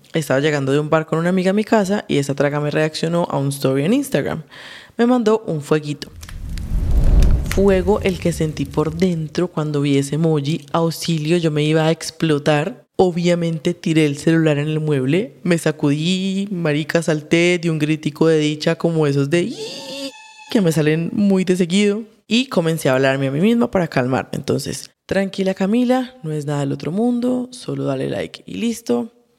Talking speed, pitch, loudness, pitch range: 185 wpm, 165 Hz, -19 LUFS, 150-195 Hz